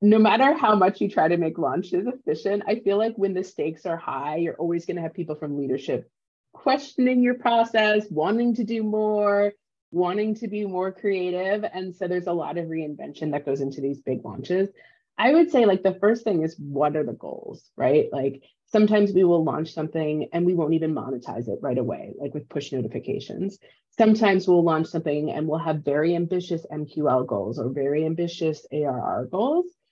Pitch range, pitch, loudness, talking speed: 150-210 Hz, 175 Hz, -24 LUFS, 195 wpm